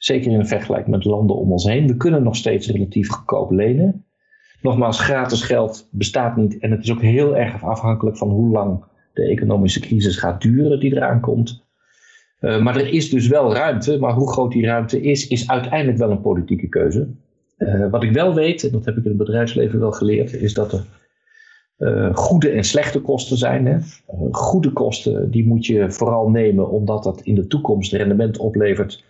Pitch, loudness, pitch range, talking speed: 115 Hz, -18 LUFS, 105-140 Hz, 195 wpm